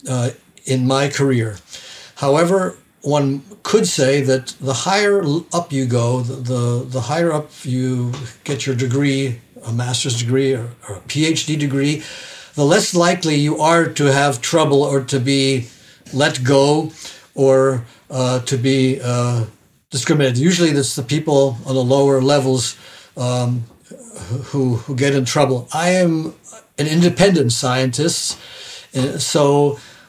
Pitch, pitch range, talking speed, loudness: 135 Hz, 130-155 Hz, 140 wpm, -17 LUFS